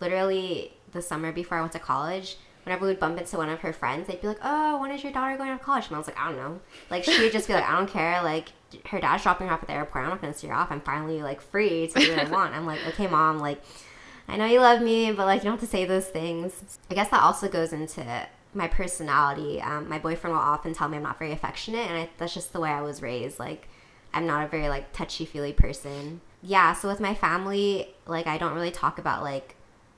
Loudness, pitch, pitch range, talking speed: -27 LUFS, 170 Hz, 155-195 Hz, 270 wpm